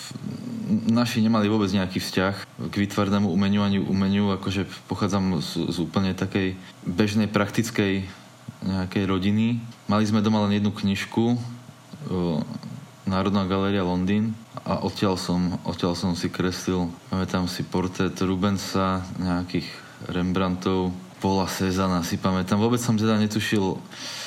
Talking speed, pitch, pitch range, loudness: 125 wpm, 95 Hz, 95-105 Hz, -25 LUFS